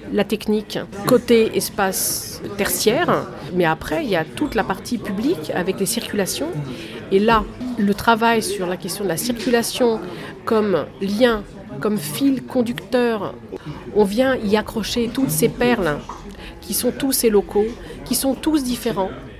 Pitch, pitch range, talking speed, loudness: 220 Hz, 195-245 Hz, 150 wpm, -20 LUFS